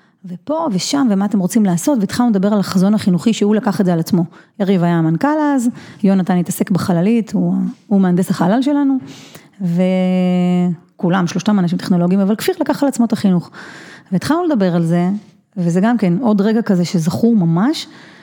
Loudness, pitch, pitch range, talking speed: -16 LUFS, 195 Hz, 180-225 Hz, 170 wpm